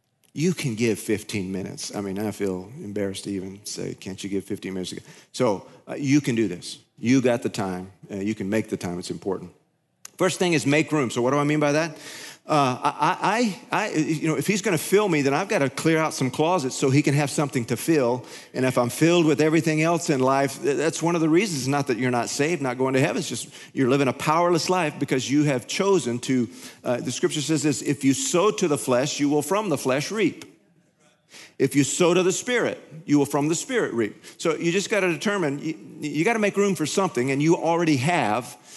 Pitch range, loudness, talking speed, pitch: 125-160 Hz, -23 LUFS, 235 wpm, 145 Hz